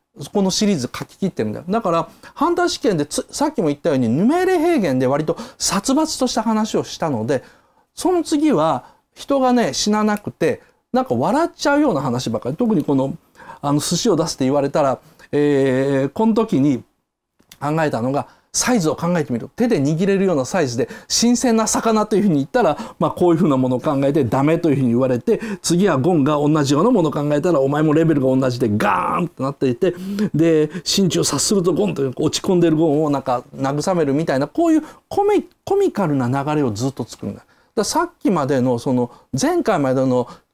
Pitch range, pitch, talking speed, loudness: 140-230 Hz, 170 Hz, 380 characters per minute, -18 LUFS